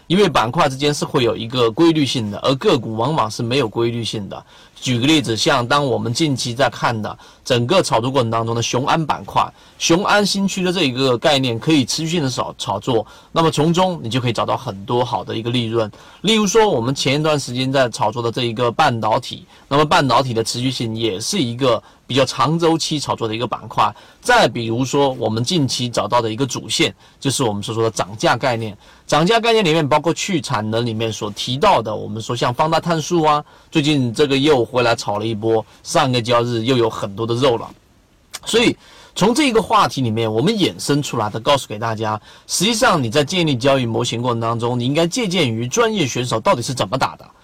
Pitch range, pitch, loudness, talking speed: 115-155 Hz, 130 Hz, -18 LUFS, 335 characters per minute